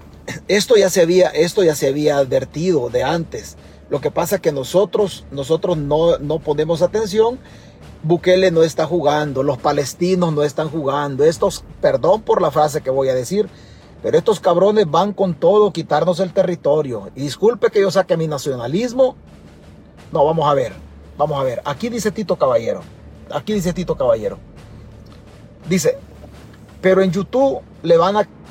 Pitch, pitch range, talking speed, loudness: 175 Hz, 150-210 Hz, 165 wpm, -17 LUFS